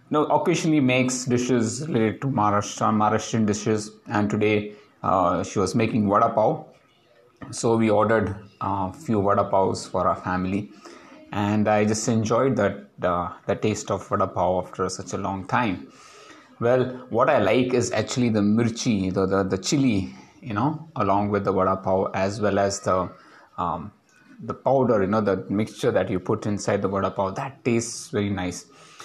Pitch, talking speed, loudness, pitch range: 105 Hz, 175 wpm, -23 LUFS, 100-120 Hz